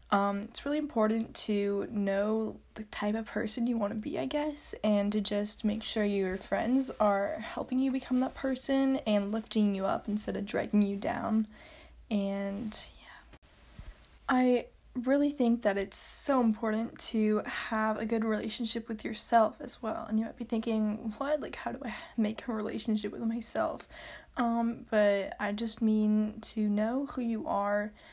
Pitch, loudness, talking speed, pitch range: 220 Hz, -31 LUFS, 175 wpm, 210-240 Hz